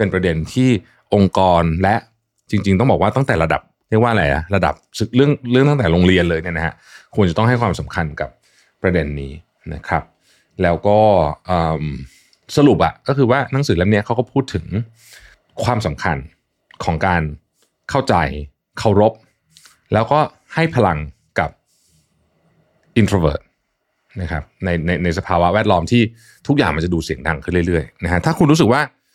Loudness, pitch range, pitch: -17 LUFS, 85-120 Hz, 95 Hz